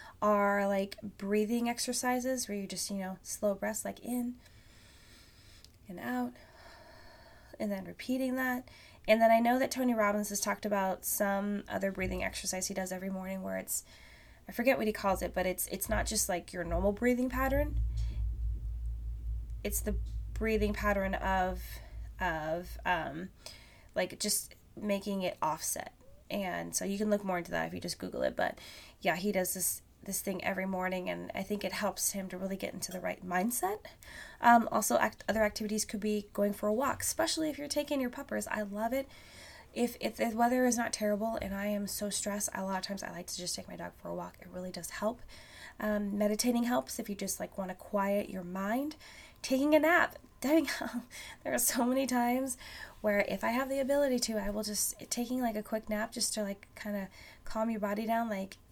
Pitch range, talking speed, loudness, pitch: 190-235 Hz, 200 wpm, -33 LUFS, 205 Hz